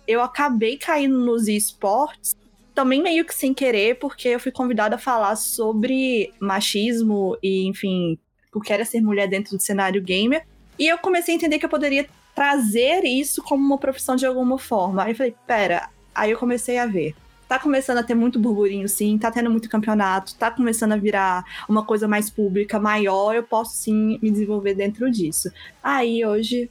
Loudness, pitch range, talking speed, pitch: -21 LUFS, 210-260 Hz, 185 wpm, 225 Hz